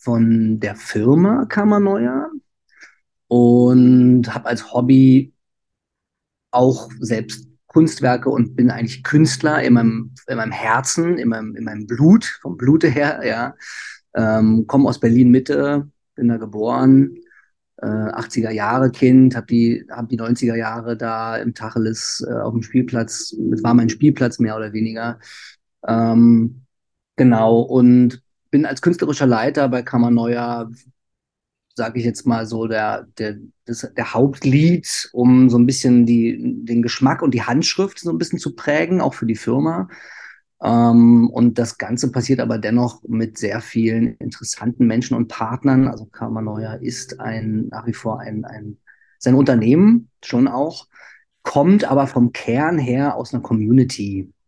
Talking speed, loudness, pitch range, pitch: 150 wpm, -17 LUFS, 115-135 Hz, 120 Hz